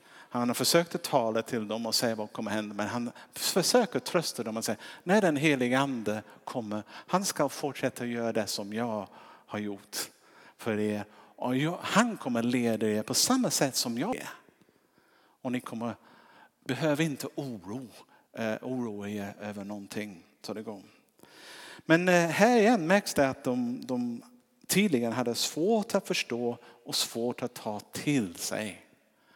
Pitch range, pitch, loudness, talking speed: 110-170 Hz, 125 Hz, -30 LUFS, 170 wpm